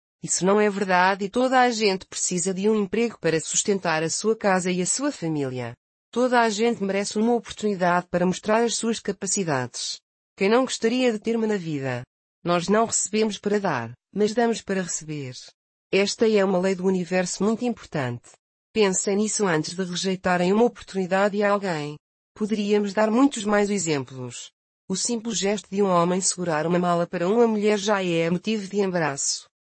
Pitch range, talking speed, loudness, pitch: 175-215 Hz, 175 wpm, -23 LUFS, 195 Hz